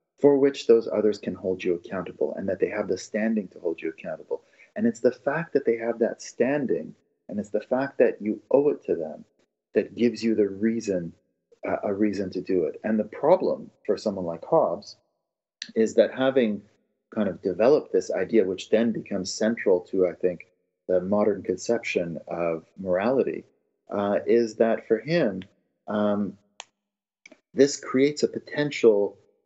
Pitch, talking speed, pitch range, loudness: 110 Hz, 175 wpm, 100-145 Hz, -25 LUFS